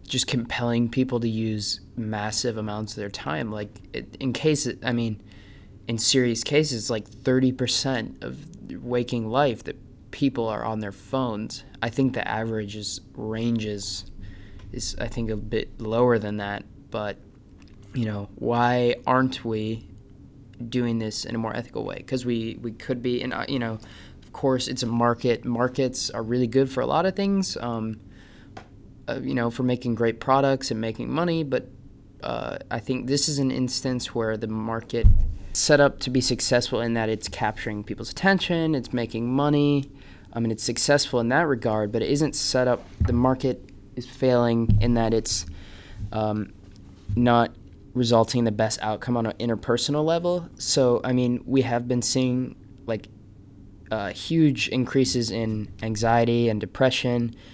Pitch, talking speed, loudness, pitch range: 115 Hz, 170 wpm, -25 LUFS, 105-130 Hz